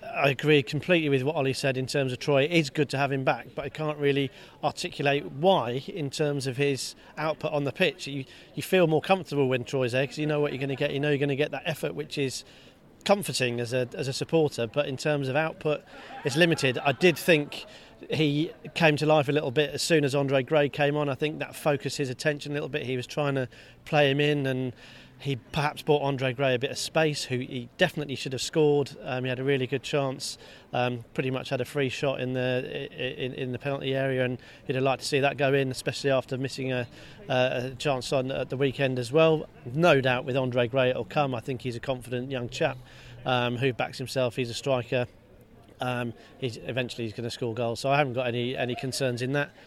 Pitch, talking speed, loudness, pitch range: 140 Hz, 250 wpm, -27 LUFS, 130-150 Hz